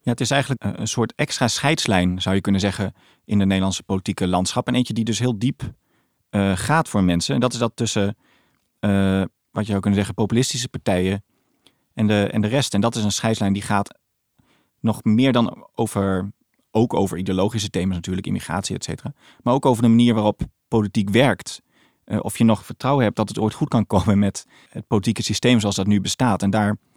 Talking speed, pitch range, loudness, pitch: 210 wpm, 100-120 Hz, -21 LUFS, 105 Hz